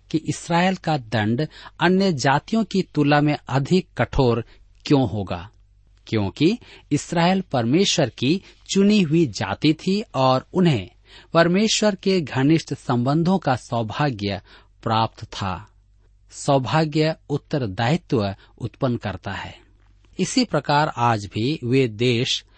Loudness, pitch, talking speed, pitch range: -21 LUFS, 135 Hz, 110 wpm, 105-160 Hz